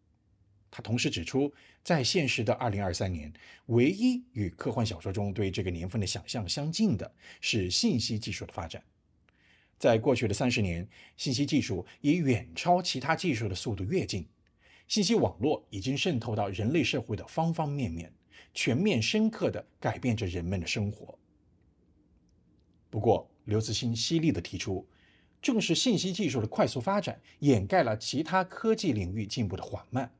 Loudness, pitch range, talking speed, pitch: -30 LUFS, 100-145 Hz, 260 characters per minute, 115 Hz